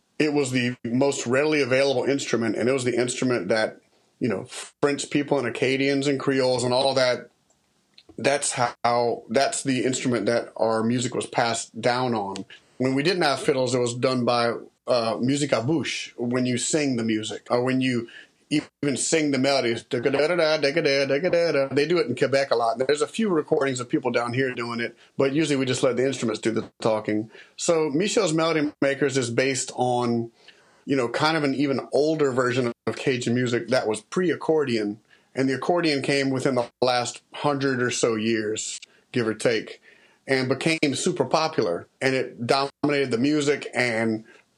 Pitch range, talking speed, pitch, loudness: 120-145 Hz, 180 wpm, 130 Hz, -24 LUFS